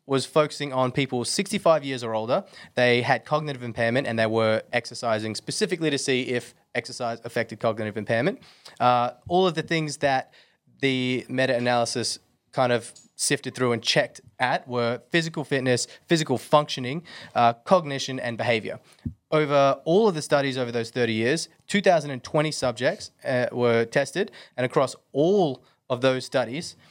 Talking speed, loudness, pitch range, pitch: 155 wpm, -25 LUFS, 120-150 Hz, 130 Hz